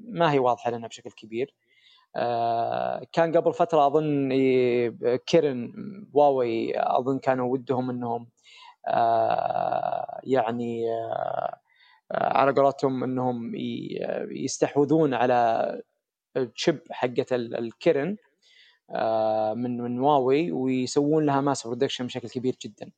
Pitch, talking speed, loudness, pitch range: 135 Hz, 90 wpm, -25 LUFS, 120-175 Hz